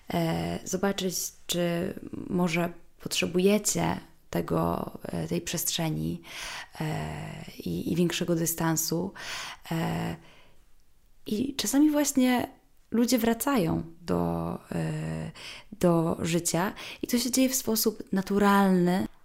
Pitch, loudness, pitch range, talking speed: 180 Hz, -28 LUFS, 165-225 Hz, 80 wpm